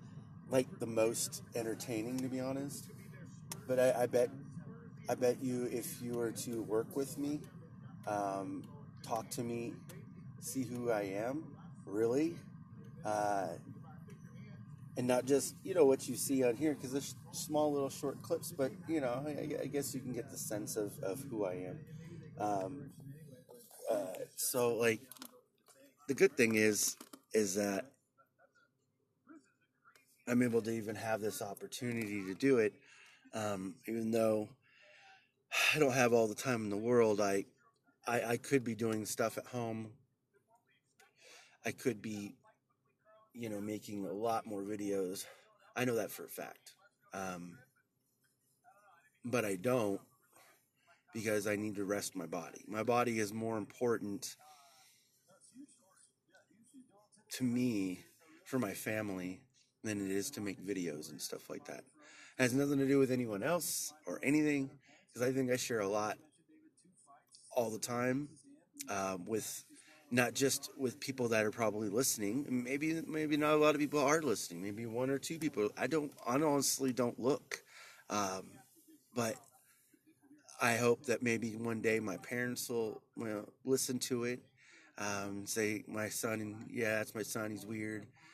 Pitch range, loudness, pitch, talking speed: 110-145 Hz, -37 LUFS, 125 Hz, 155 wpm